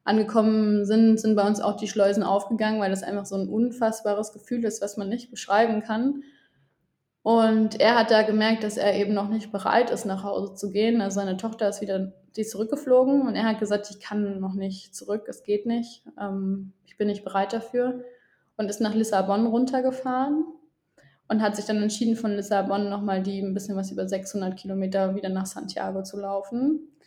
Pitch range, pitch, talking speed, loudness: 195-225 Hz, 210 Hz, 195 wpm, -25 LUFS